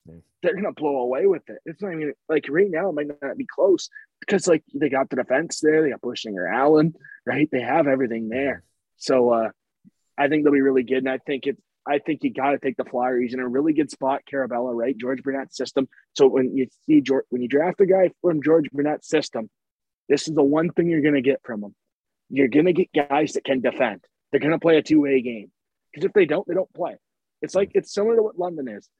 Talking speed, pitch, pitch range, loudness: 240 wpm, 145 Hz, 130-165 Hz, -22 LUFS